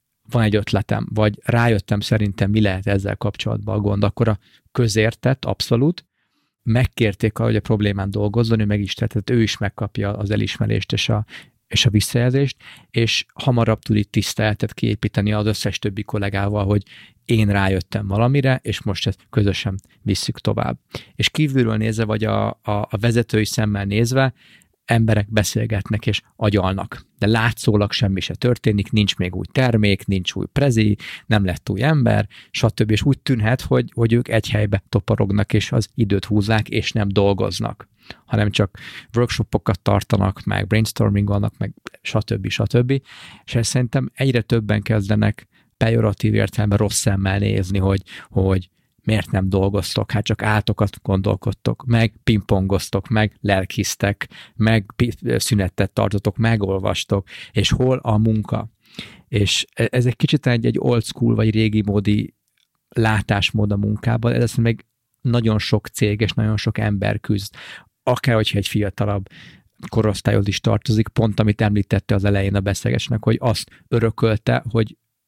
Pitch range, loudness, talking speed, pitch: 100-115 Hz, -20 LUFS, 145 wpm, 110 Hz